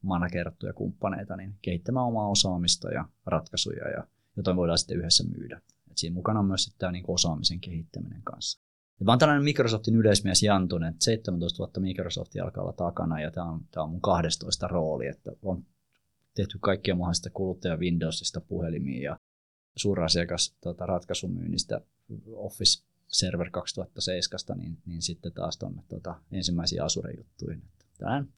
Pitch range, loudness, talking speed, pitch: 85-100 Hz, -28 LUFS, 145 wpm, 90 Hz